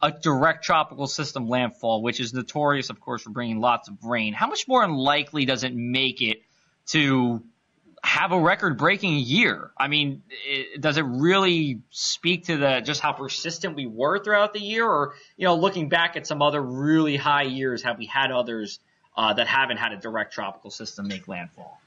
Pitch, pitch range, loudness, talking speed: 140 Hz, 125-160 Hz, -23 LUFS, 190 wpm